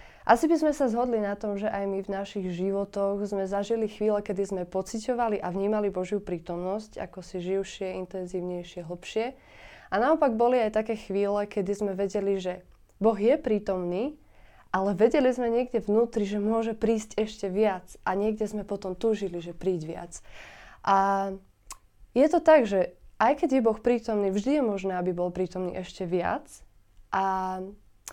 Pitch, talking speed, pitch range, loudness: 200 Hz, 165 wpm, 190-225 Hz, -27 LUFS